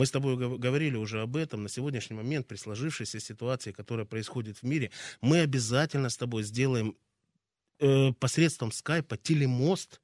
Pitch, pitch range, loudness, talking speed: 125 Hz, 110-140 Hz, -30 LUFS, 160 wpm